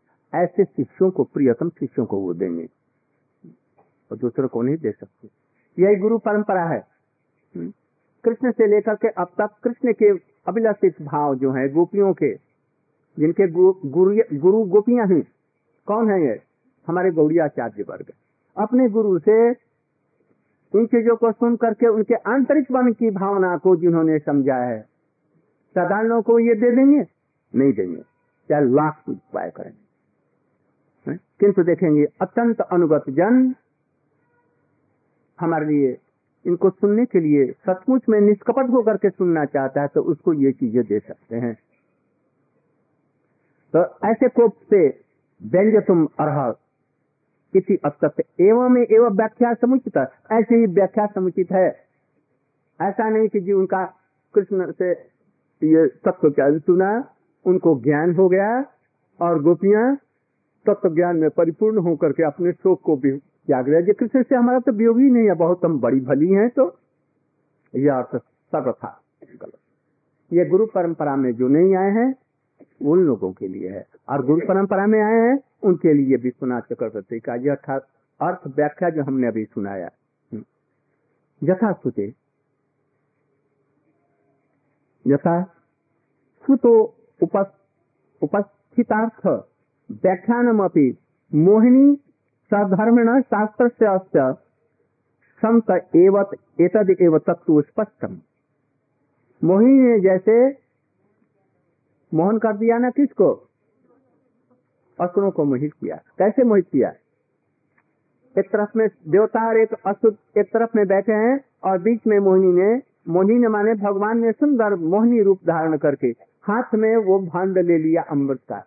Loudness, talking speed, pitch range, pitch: -19 LUFS, 120 wpm, 150-220 Hz, 185 Hz